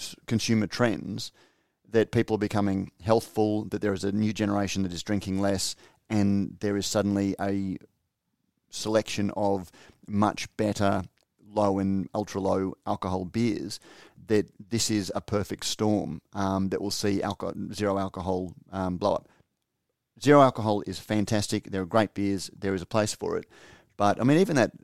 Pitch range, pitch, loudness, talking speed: 95-105 Hz, 100 Hz, -27 LUFS, 160 wpm